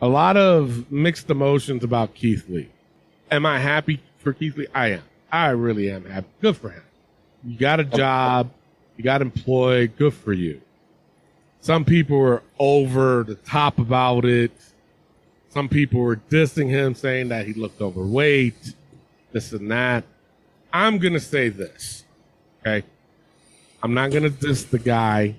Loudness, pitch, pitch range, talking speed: -21 LUFS, 130 Hz, 115-145 Hz, 160 wpm